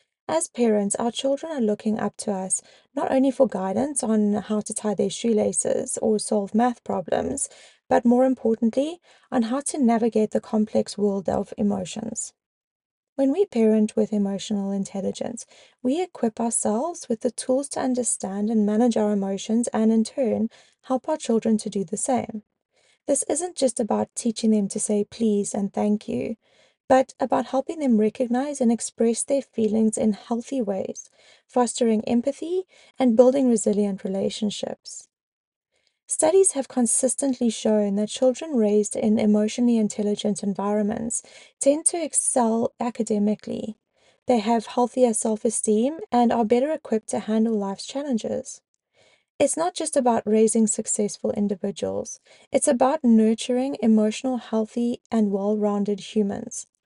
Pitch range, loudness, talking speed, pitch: 215-255 Hz, -23 LUFS, 140 wpm, 230 Hz